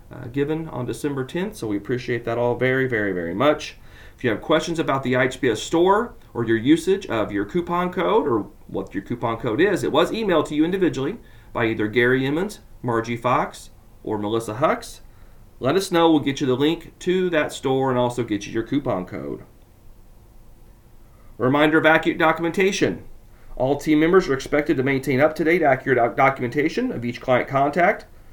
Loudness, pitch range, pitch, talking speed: -21 LUFS, 115-155 Hz, 130 Hz, 190 wpm